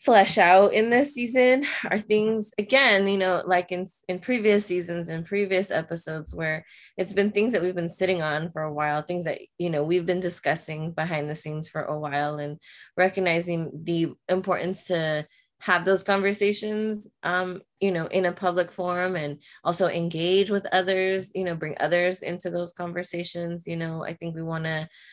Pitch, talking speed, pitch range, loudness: 180 Hz, 185 wpm, 165-195 Hz, -25 LUFS